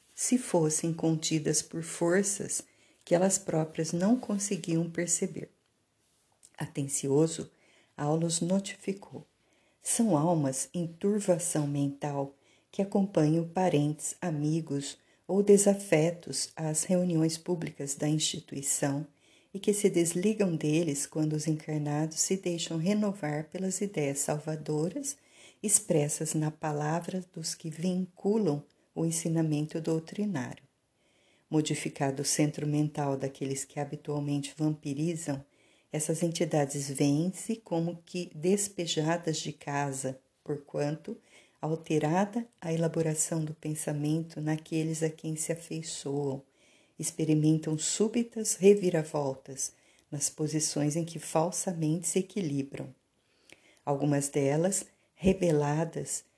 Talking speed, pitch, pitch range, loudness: 100 wpm, 160 Hz, 150-180 Hz, -30 LUFS